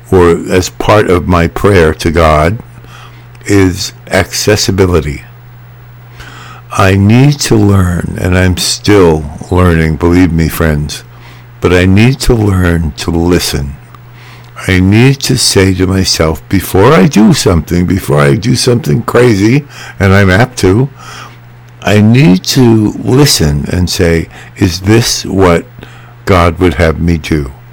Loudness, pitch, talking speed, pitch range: -8 LUFS, 95 Hz, 130 wpm, 85-120 Hz